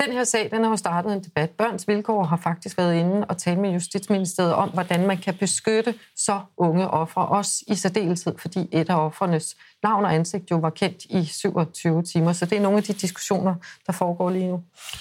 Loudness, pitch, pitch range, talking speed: -23 LUFS, 185 Hz, 170-205 Hz, 215 wpm